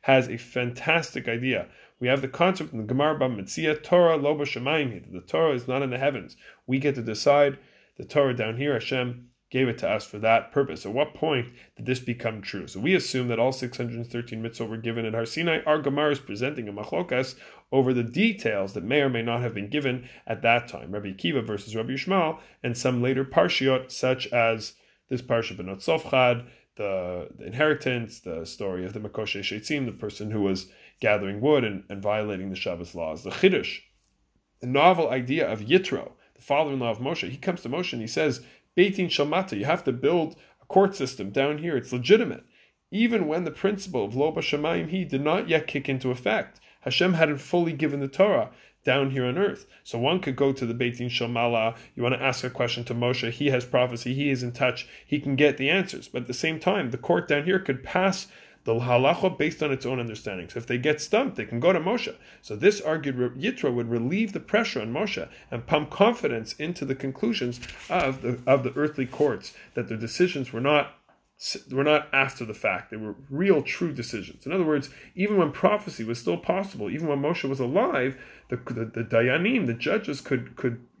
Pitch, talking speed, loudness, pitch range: 130 Hz, 205 wpm, -26 LUFS, 120-150 Hz